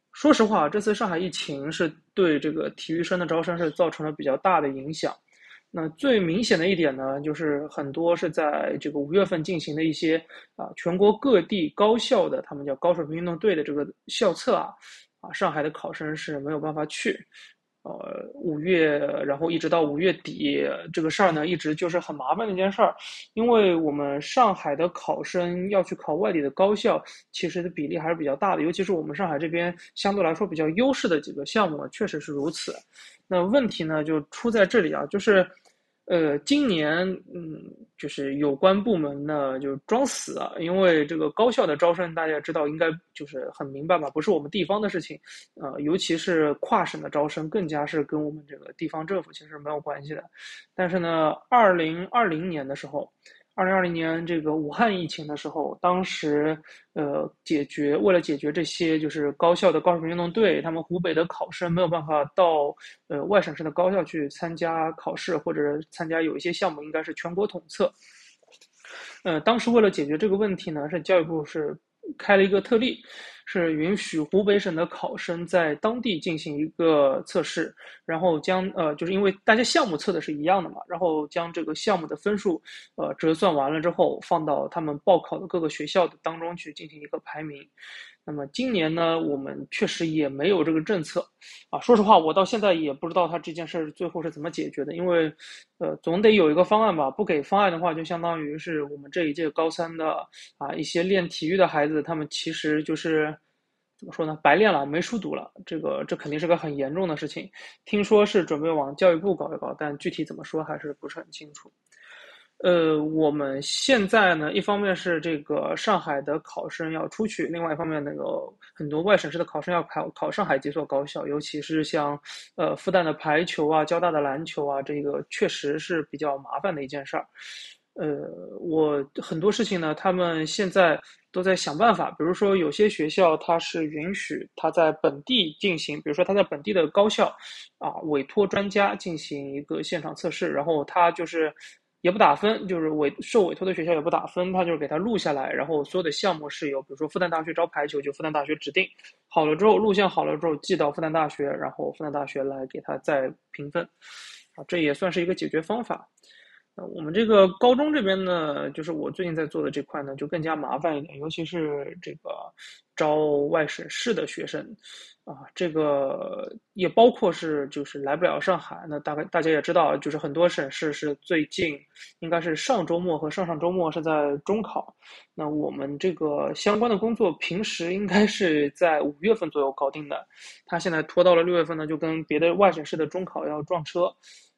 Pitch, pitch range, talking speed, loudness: 165 Hz, 150-185 Hz, 305 characters per minute, -25 LUFS